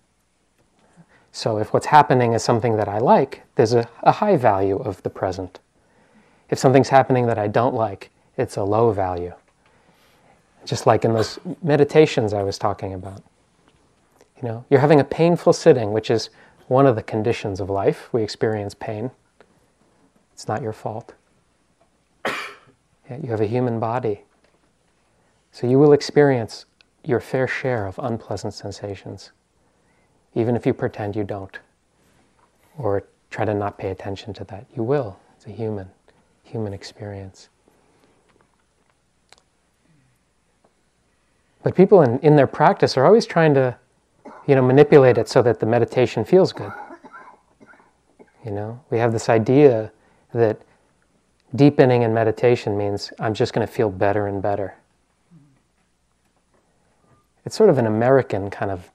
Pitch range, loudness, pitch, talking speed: 100-130 Hz, -19 LUFS, 115 Hz, 145 wpm